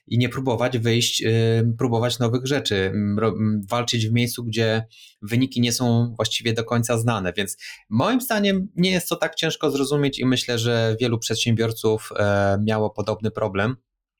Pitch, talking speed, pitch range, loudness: 115 Hz, 160 wpm, 110-125 Hz, -22 LUFS